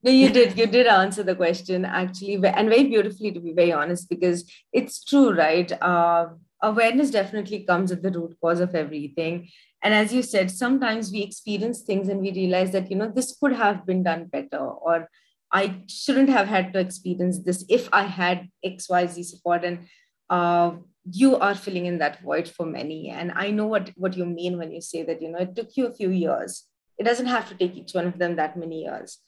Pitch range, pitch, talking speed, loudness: 175-210 Hz, 185 Hz, 215 wpm, -23 LUFS